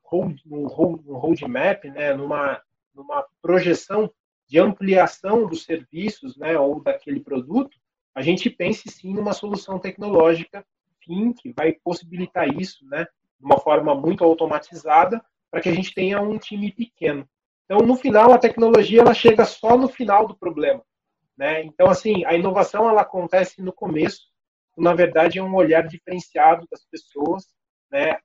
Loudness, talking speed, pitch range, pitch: -20 LUFS, 155 wpm, 165-220 Hz, 185 Hz